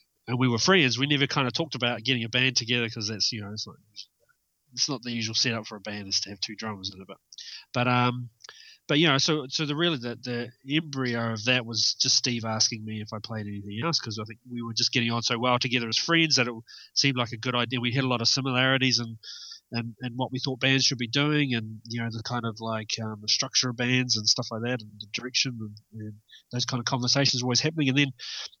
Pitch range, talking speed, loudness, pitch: 110-130 Hz, 265 wpm, -26 LUFS, 120 Hz